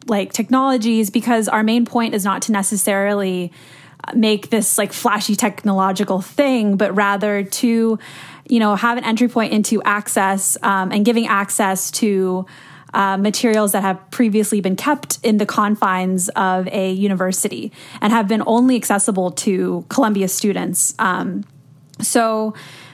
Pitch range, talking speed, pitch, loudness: 190-225 Hz, 145 wpm, 210 Hz, -17 LUFS